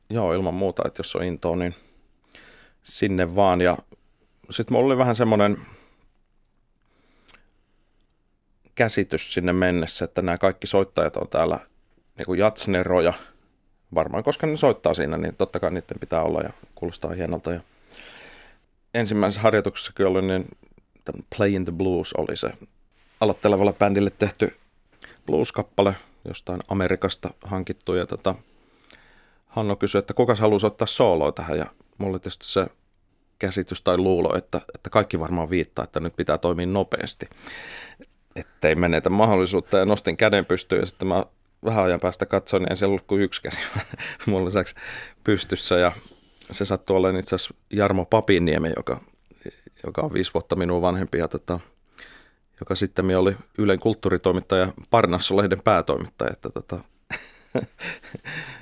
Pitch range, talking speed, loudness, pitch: 90-100 Hz, 135 wpm, -23 LUFS, 95 Hz